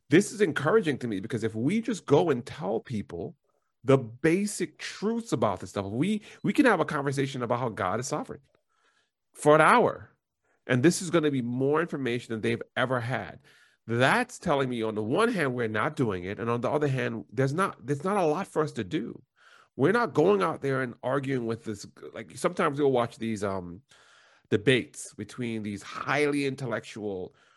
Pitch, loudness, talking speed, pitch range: 135 Hz, -27 LUFS, 200 wpm, 115-155 Hz